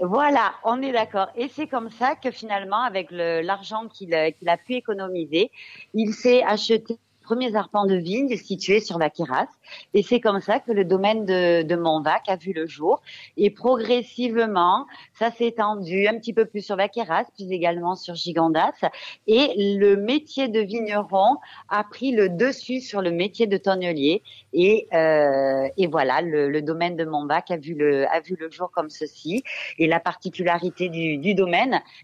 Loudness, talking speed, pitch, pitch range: -23 LUFS, 180 wpm, 195 Hz, 170-230 Hz